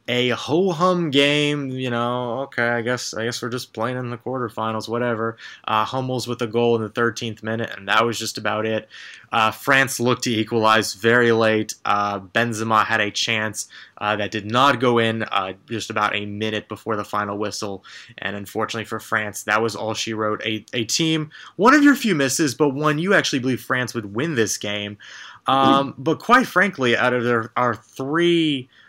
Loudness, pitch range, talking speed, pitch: -21 LUFS, 110-130 Hz, 200 wpm, 115 Hz